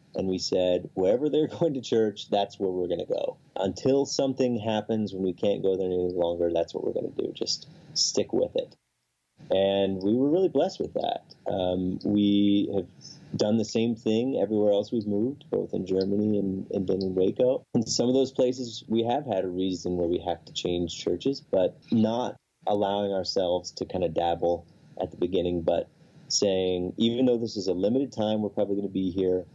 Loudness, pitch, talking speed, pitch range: -27 LUFS, 100 Hz, 200 wpm, 95-115 Hz